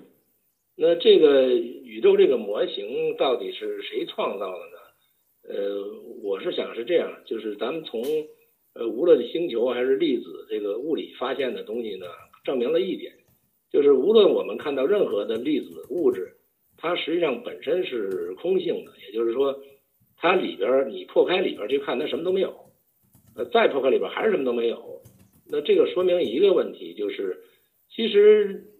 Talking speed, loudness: 260 characters per minute, -24 LUFS